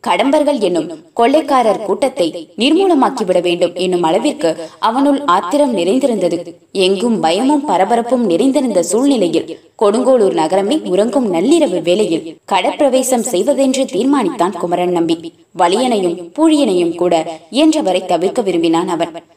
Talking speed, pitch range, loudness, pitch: 100 wpm, 175-280 Hz, -14 LUFS, 205 Hz